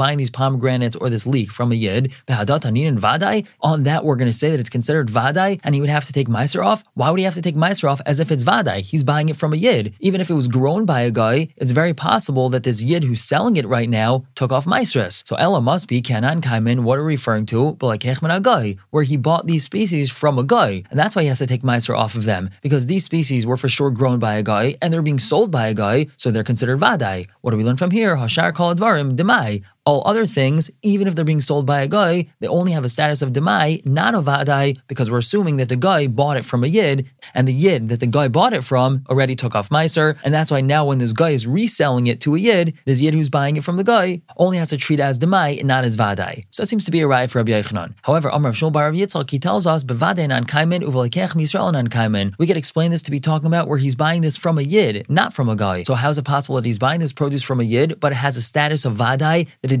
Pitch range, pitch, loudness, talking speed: 125-160 Hz, 140 Hz, -18 LUFS, 265 wpm